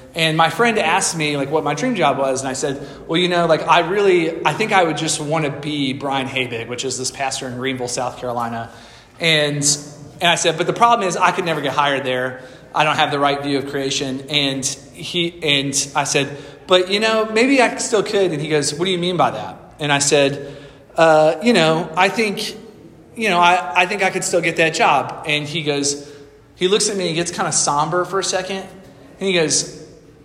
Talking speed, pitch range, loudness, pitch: 235 wpm, 140-180 Hz, -17 LUFS, 155 Hz